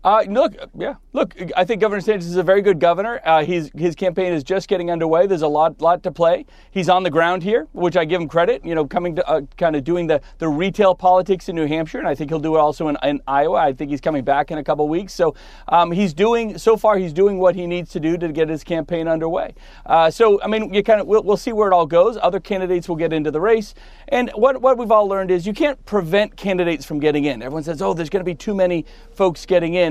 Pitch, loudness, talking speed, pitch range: 180 Hz, -18 LUFS, 270 wpm, 160-200 Hz